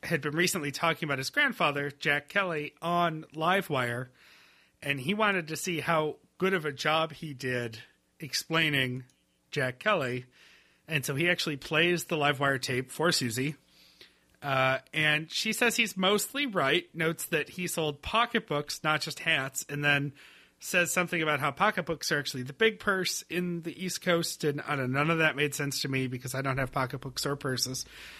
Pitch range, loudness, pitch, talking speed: 135-175 Hz, -29 LUFS, 150 Hz, 185 wpm